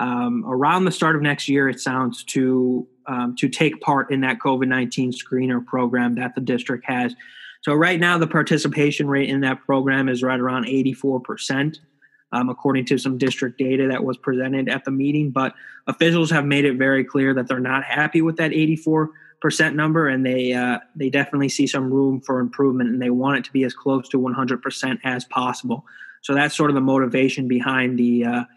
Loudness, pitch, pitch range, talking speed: -20 LUFS, 135 Hz, 125-145 Hz, 210 wpm